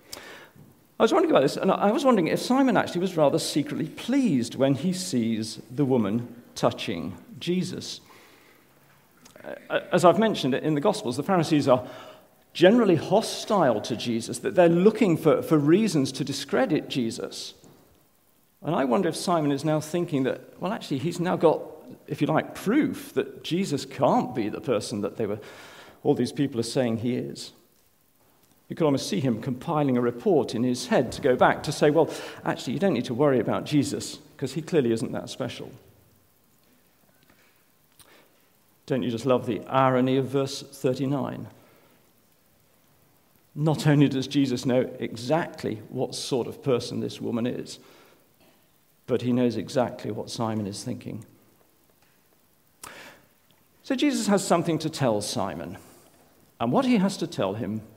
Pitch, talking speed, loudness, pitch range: 140 Hz, 160 wpm, -25 LUFS, 125-170 Hz